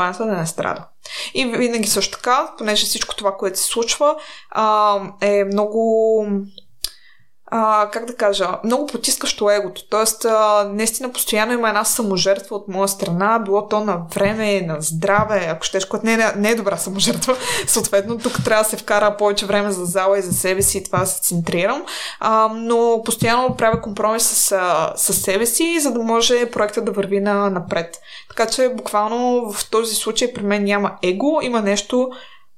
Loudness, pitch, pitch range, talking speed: -18 LUFS, 215 Hz, 200-230 Hz, 175 wpm